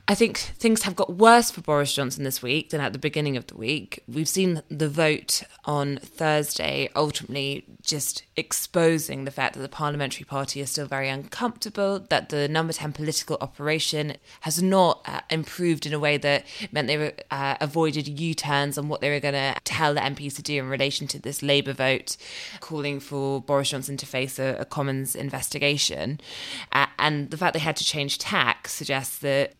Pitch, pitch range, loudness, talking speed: 145 Hz, 140-160 Hz, -25 LUFS, 195 wpm